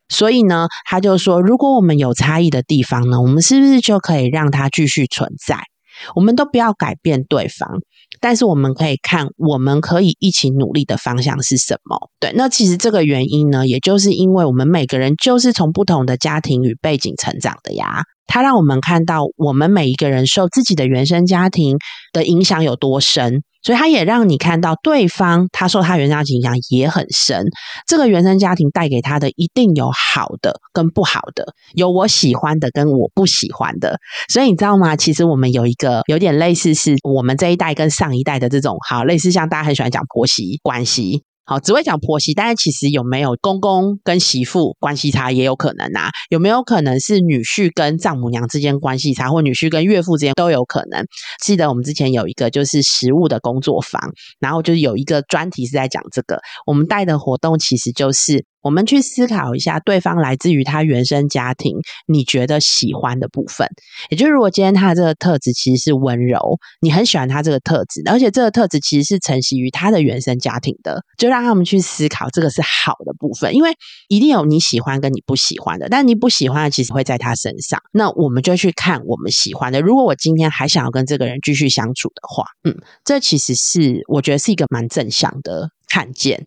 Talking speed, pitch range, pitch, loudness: 330 characters per minute, 135-185 Hz, 155 Hz, -15 LUFS